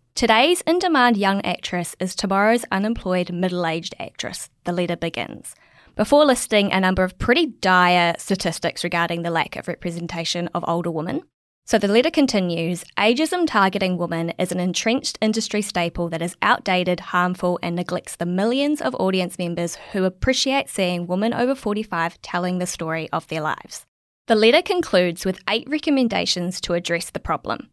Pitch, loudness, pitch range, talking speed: 180 Hz, -21 LUFS, 175-220 Hz, 160 wpm